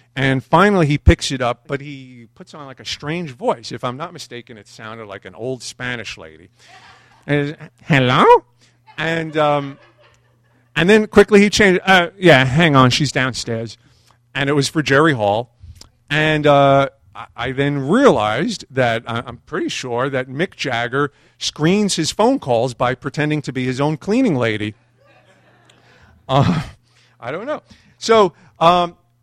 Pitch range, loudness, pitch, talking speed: 120-155 Hz, -16 LUFS, 135 Hz, 160 wpm